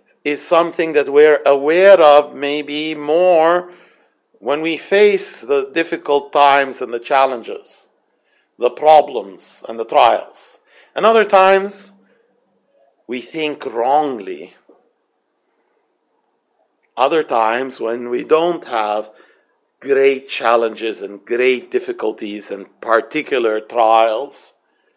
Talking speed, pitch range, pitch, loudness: 100 wpm, 130-195 Hz, 150 Hz, -15 LUFS